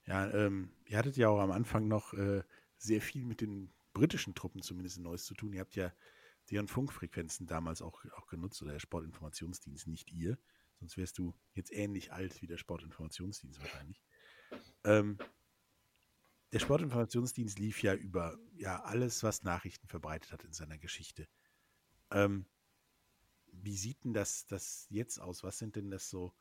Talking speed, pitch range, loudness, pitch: 165 wpm, 85-105 Hz, -39 LUFS, 95 Hz